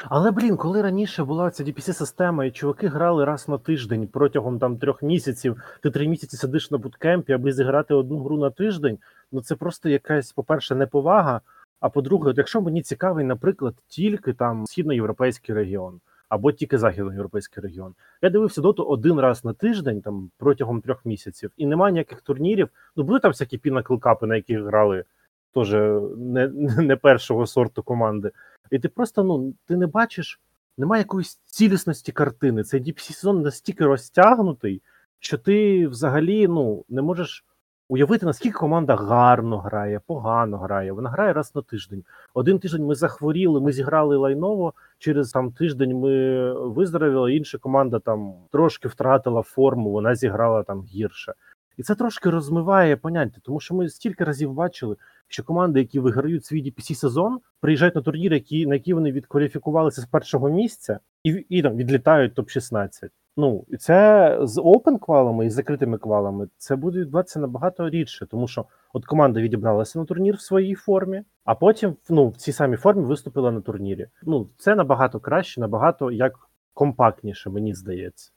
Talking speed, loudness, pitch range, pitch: 165 wpm, -22 LUFS, 125-170 Hz, 140 Hz